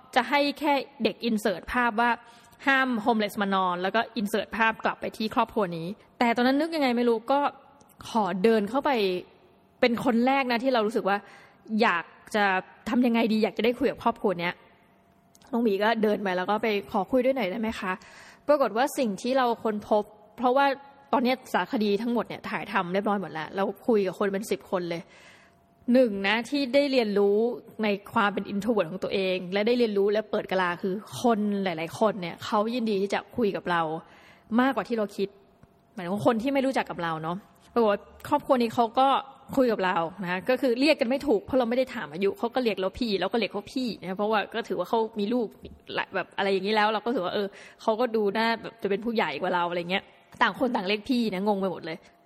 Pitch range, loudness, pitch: 195-245 Hz, -26 LUFS, 220 Hz